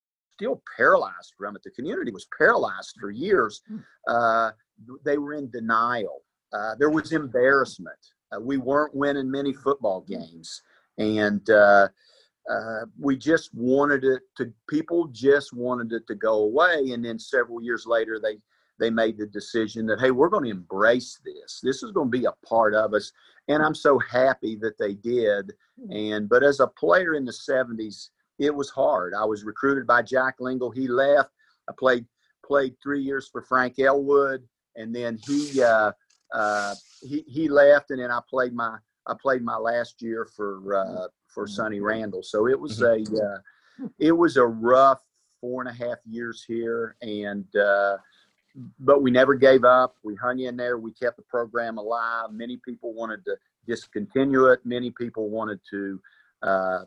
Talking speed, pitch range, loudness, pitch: 175 wpm, 110-135 Hz, -24 LUFS, 120 Hz